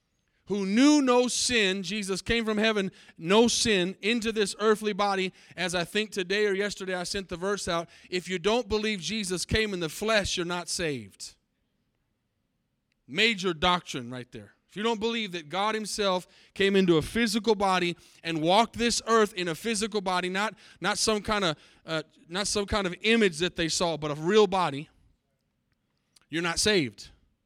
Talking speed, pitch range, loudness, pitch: 180 wpm, 175-215 Hz, -27 LUFS, 195 Hz